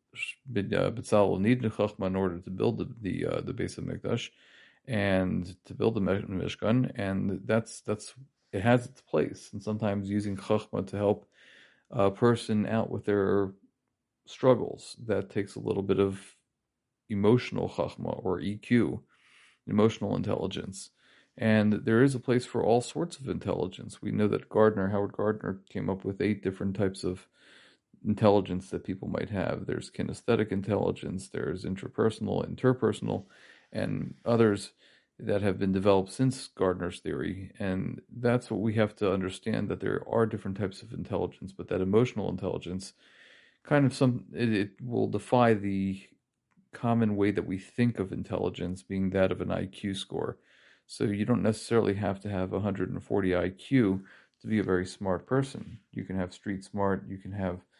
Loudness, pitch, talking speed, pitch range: -30 LUFS, 100 Hz, 160 wpm, 95-115 Hz